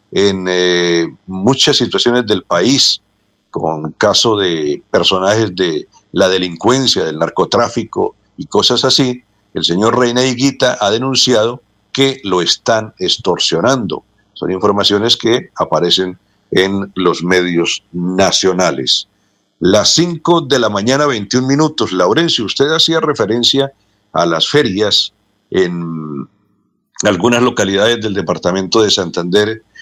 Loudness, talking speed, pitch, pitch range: -13 LUFS, 115 wpm, 110 Hz, 95-135 Hz